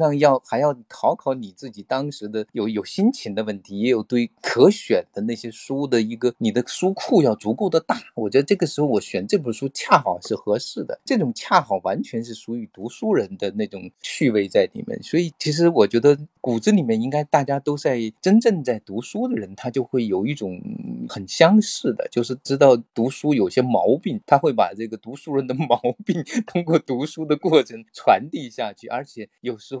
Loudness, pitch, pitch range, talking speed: -21 LUFS, 130 Hz, 115-160 Hz, 300 characters per minute